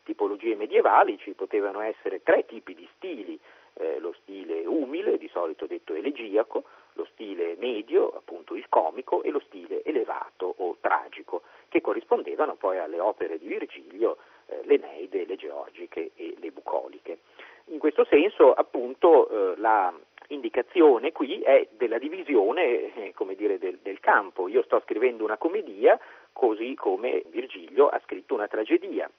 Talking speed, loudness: 145 wpm, -26 LUFS